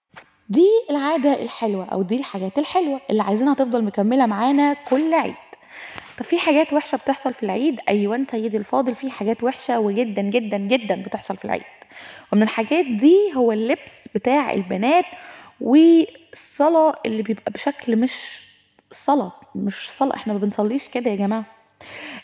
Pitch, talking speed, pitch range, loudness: 250 Hz, 145 wpm, 220-290 Hz, -20 LUFS